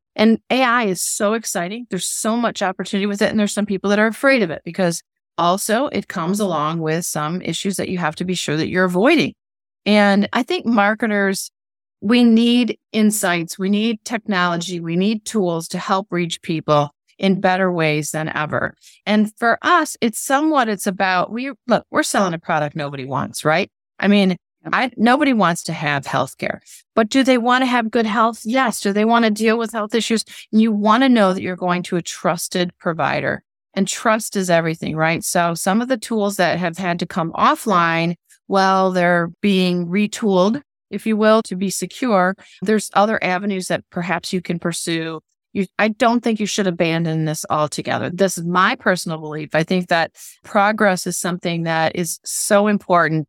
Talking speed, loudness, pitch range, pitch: 190 wpm, -18 LUFS, 175-220 Hz, 195 Hz